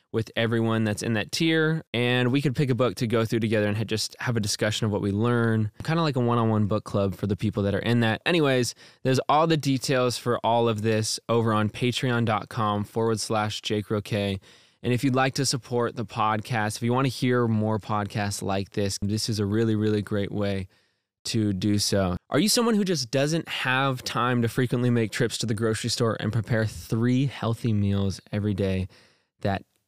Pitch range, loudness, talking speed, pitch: 105-125 Hz, -25 LUFS, 215 wpm, 115 Hz